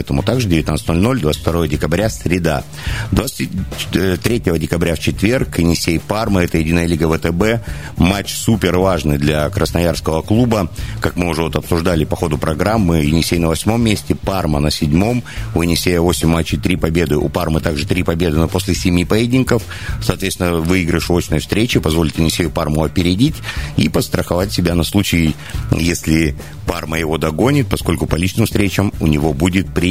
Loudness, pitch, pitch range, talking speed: -16 LUFS, 85 Hz, 80-95 Hz, 155 wpm